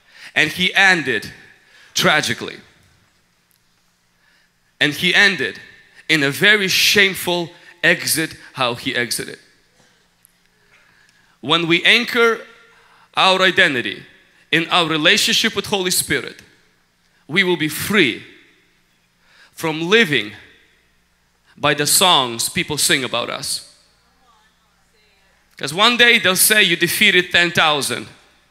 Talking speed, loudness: 100 wpm, -15 LUFS